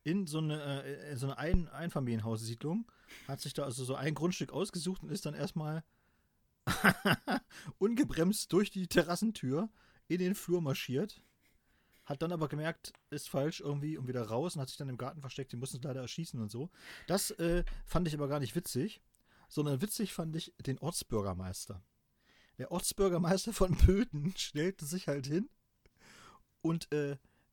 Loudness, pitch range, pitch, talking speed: -36 LUFS, 135-175 Hz, 150 Hz, 165 wpm